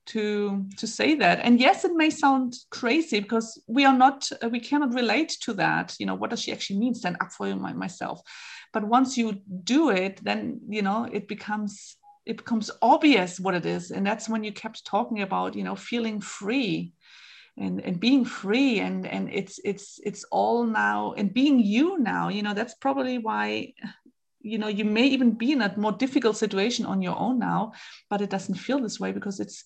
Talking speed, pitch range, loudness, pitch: 210 wpm, 200-255 Hz, -25 LUFS, 220 Hz